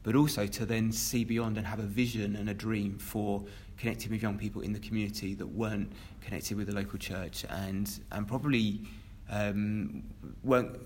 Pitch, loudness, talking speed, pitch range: 105 Hz, -34 LUFS, 180 wpm, 100-110 Hz